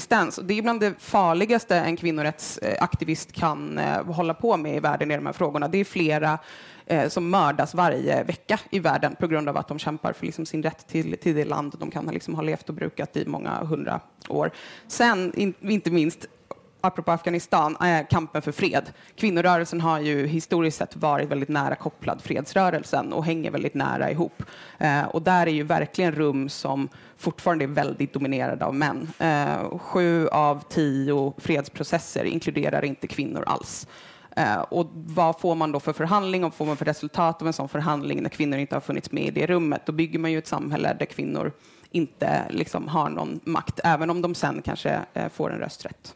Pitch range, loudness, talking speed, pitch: 150-175 Hz, -25 LUFS, 190 wpm, 160 Hz